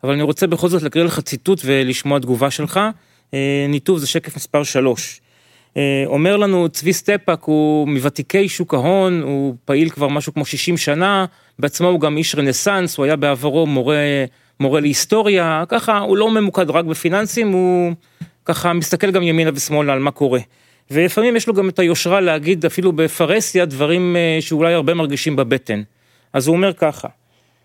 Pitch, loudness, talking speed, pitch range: 160 Hz, -16 LUFS, 165 wpm, 140-180 Hz